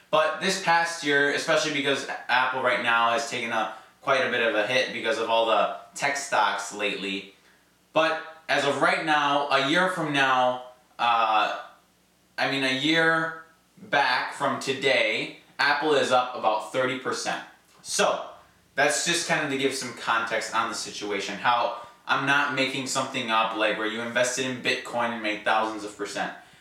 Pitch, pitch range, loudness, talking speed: 125 Hz, 110-145 Hz, -25 LUFS, 170 wpm